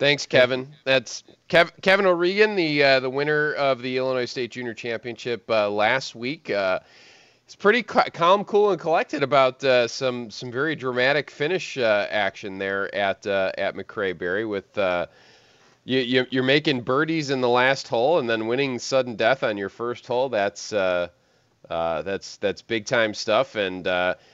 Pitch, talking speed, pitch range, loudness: 130 Hz, 175 wpm, 115-145 Hz, -23 LUFS